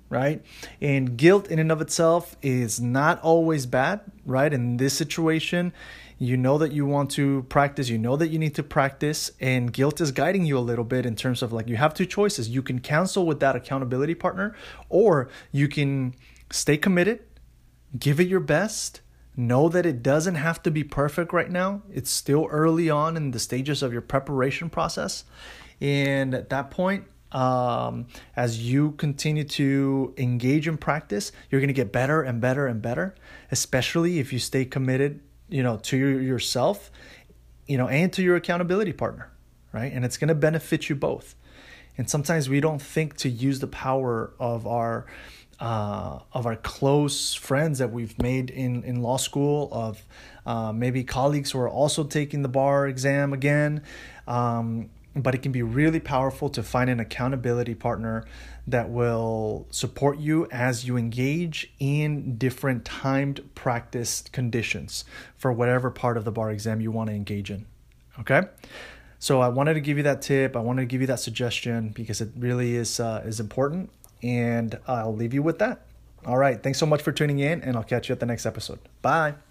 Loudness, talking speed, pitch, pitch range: -25 LUFS, 185 wpm, 135 Hz, 120-150 Hz